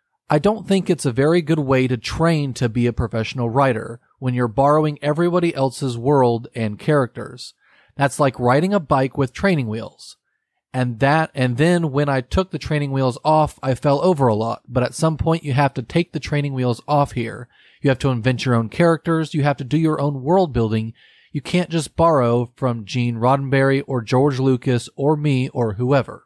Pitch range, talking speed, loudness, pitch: 125-155 Hz, 205 wpm, -19 LUFS, 135 Hz